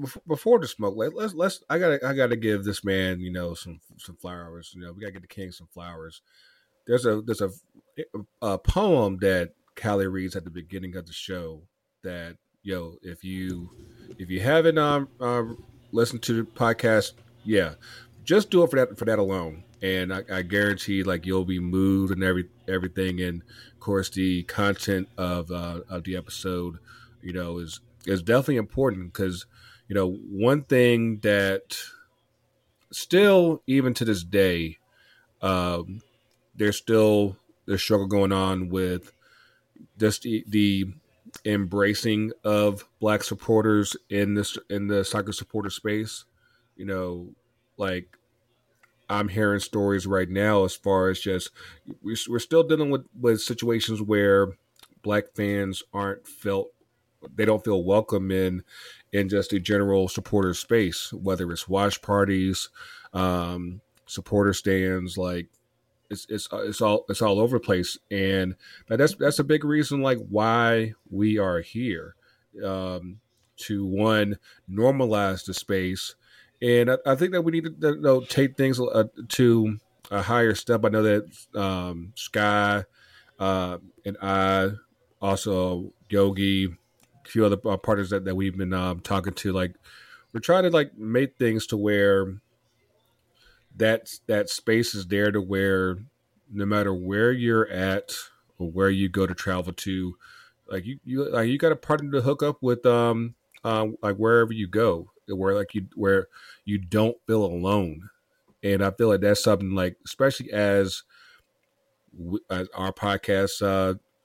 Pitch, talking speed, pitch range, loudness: 100 Hz, 155 wpm, 95-115 Hz, -25 LUFS